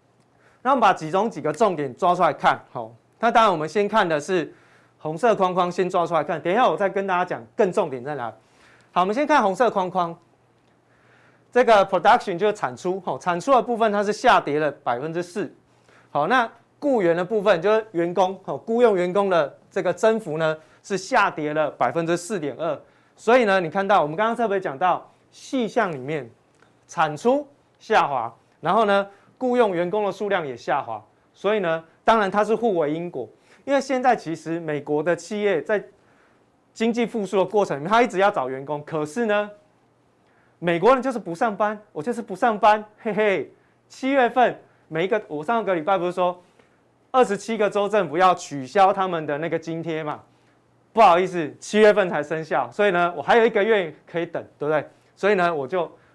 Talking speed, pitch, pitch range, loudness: 295 characters per minute, 190 Hz, 170-220 Hz, -22 LUFS